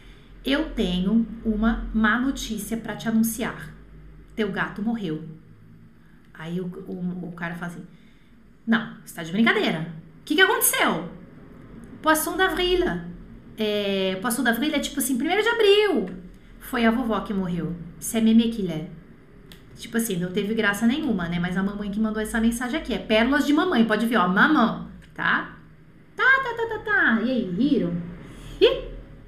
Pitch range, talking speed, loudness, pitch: 180-250 Hz, 160 wpm, -23 LUFS, 220 Hz